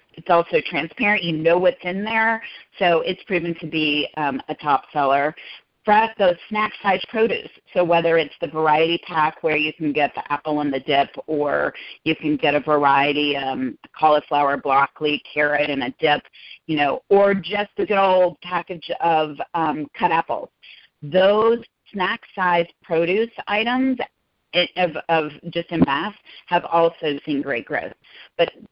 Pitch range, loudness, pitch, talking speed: 150-190 Hz, -20 LUFS, 170 Hz, 160 wpm